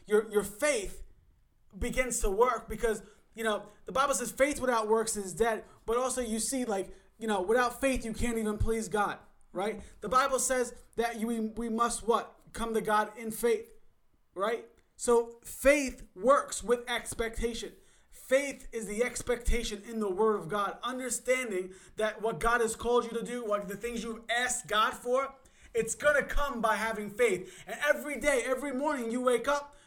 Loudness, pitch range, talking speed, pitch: -31 LUFS, 220-255 Hz, 180 wpm, 230 Hz